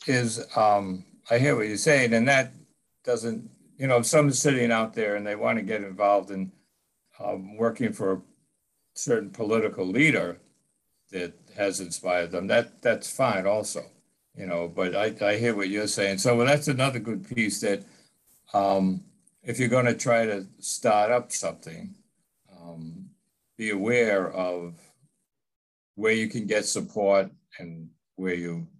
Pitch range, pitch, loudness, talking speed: 95-120 Hz, 105 Hz, -25 LUFS, 160 wpm